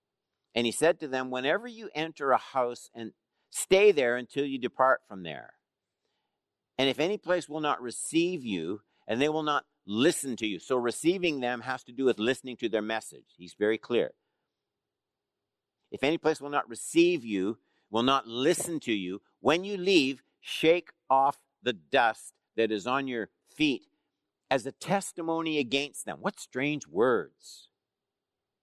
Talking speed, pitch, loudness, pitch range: 165 wpm, 140 Hz, -29 LUFS, 120-165 Hz